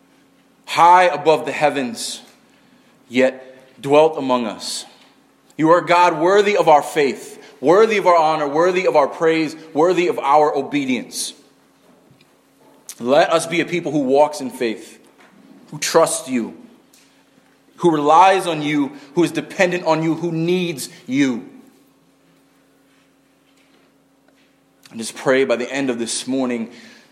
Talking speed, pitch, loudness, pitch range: 135 wpm, 160 Hz, -17 LUFS, 145-185 Hz